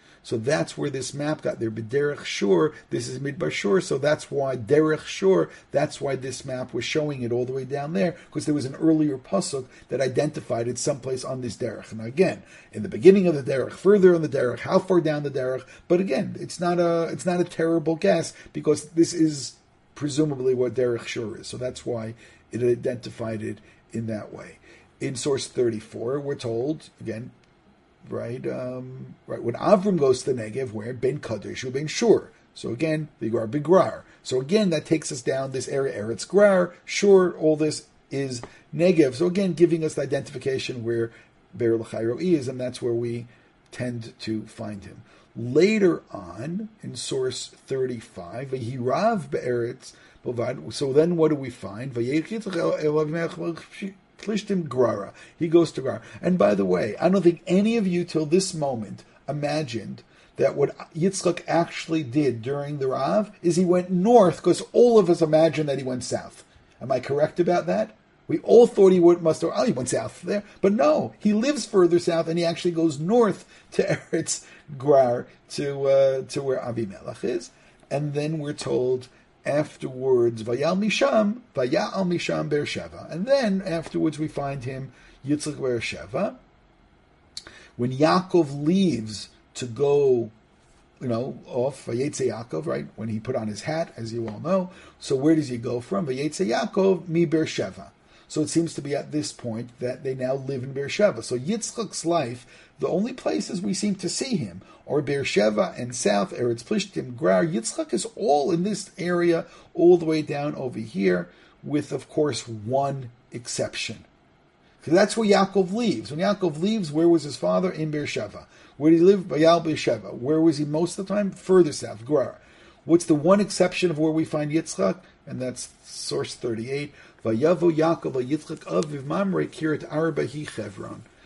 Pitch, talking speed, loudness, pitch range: 155 Hz, 175 wpm, -24 LUFS, 125-175 Hz